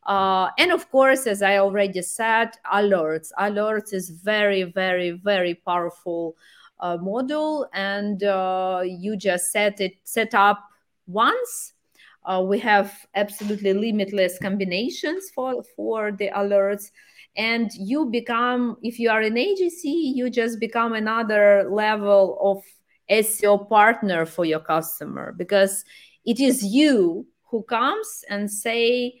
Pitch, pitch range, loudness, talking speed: 205 Hz, 195-235 Hz, -22 LUFS, 130 wpm